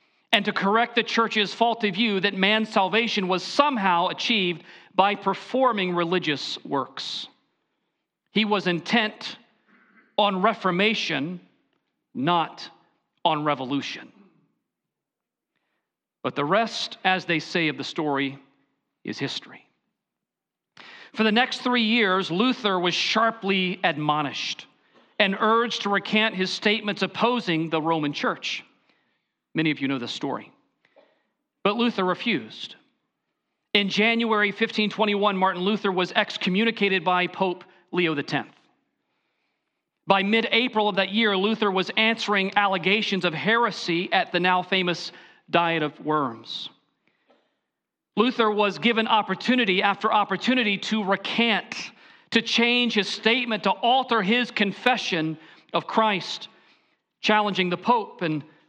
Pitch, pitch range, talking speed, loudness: 200 Hz, 180-225 Hz, 120 wpm, -23 LUFS